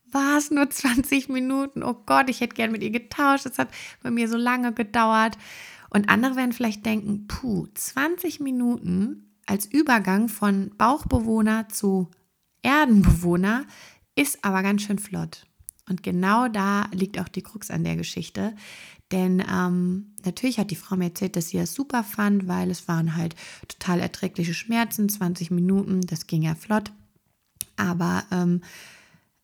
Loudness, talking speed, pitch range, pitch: -24 LUFS, 160 wpm, 180-240 Hz, 205 Hz